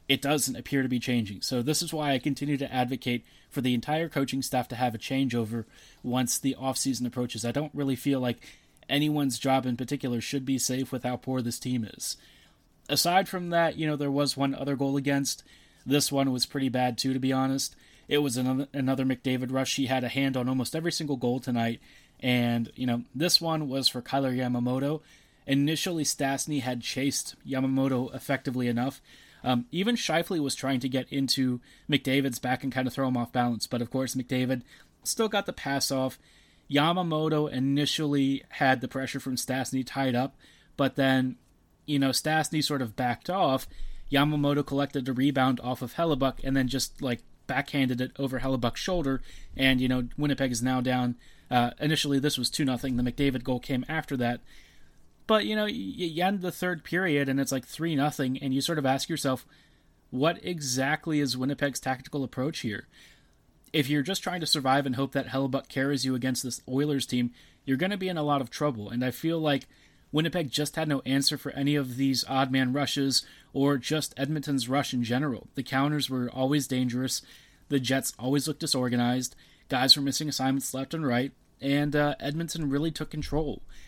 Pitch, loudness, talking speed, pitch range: 135 Hz, -28 LUFS, 195 wpm, 125-145 Hz